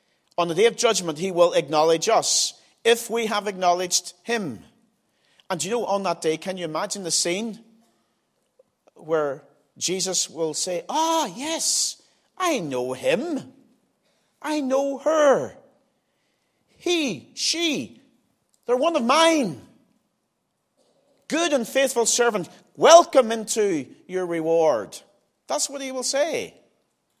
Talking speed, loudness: 125 wpm, -22 LUFS